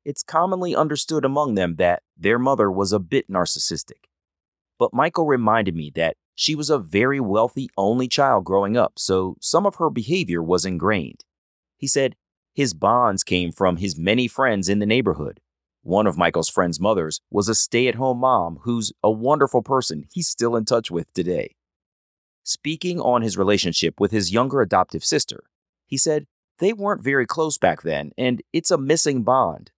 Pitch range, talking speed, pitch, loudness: 100-140 Hz, 175 wpm, 120 Hz, -21 LUFS